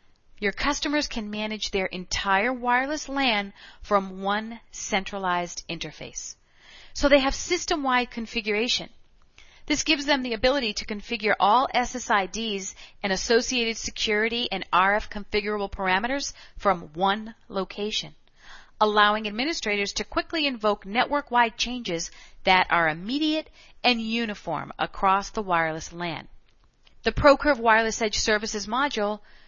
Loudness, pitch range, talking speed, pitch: -25 LUFS, 195-245 Hz, 120 wpm, 215 Hz